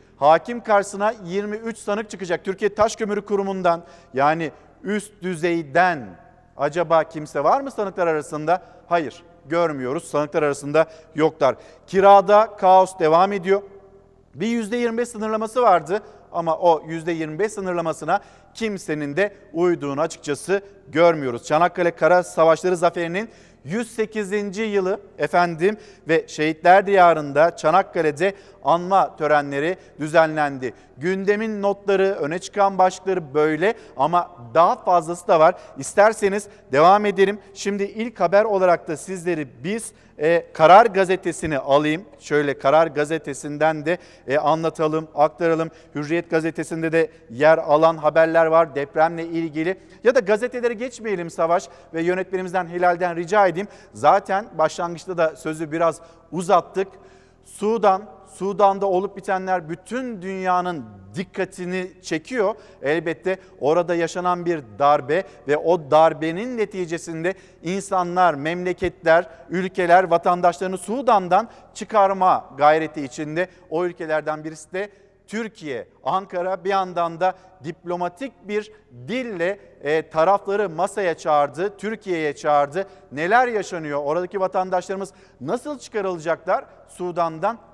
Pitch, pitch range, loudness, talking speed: 180 Hz, 160-200 Hz, -21 LUFS, 110 wpm